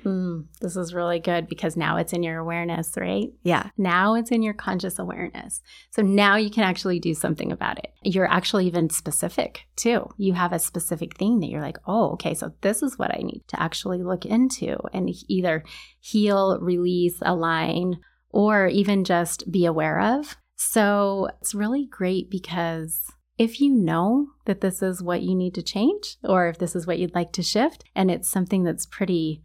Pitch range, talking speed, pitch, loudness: 175-210 Hz, 190 wpm, 185 Hz, -24 LUFS